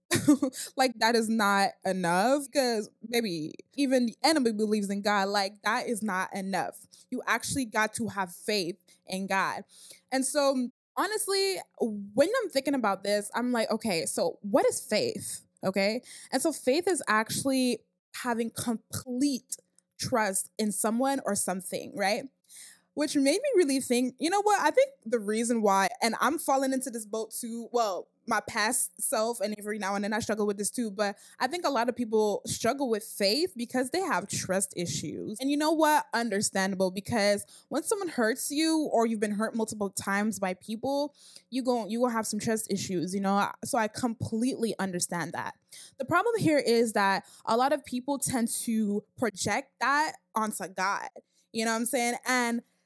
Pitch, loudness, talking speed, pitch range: 225 Hz, -29 LUFS, 180 wpm, 205-260 Hz